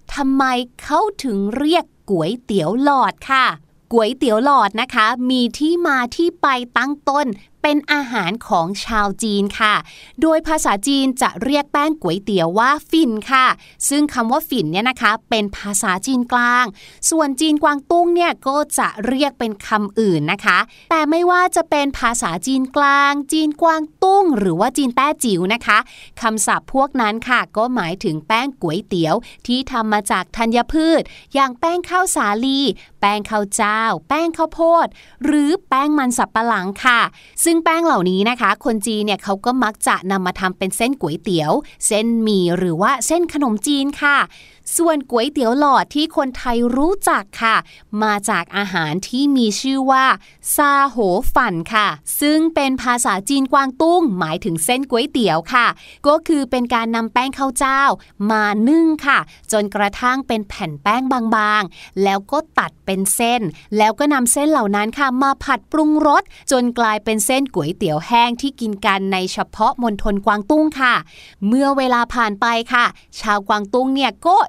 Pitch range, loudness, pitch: 210-285 Hz, -17 LUFS, 245 Hz